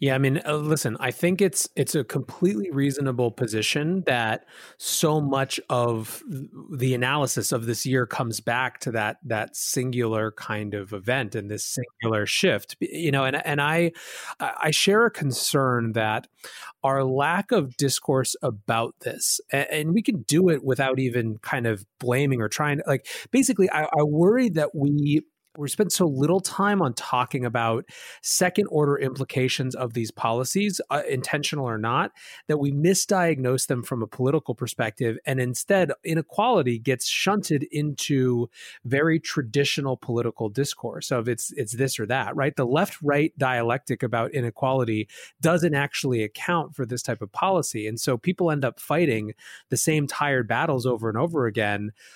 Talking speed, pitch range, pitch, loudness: 160 wpm, 120-155 Hz, 135 Hz, -24 LUFS